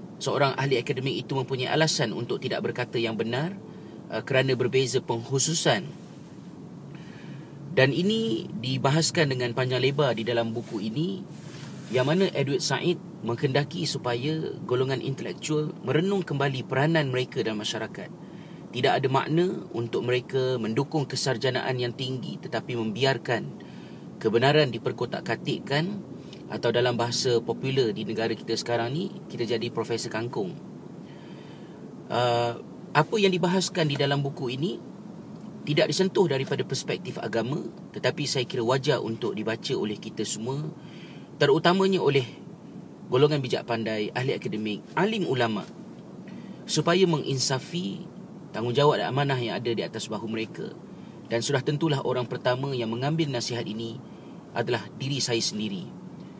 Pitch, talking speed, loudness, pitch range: 135 Hz, 125 wpm, -27 LUFS, 120-160 Hz